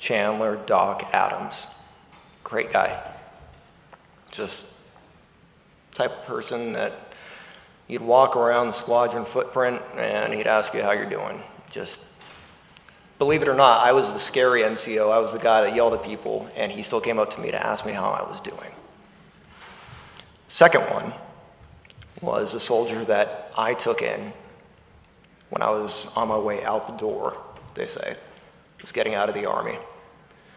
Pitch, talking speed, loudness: 120 Hz, 160 wpm, -23 LUFS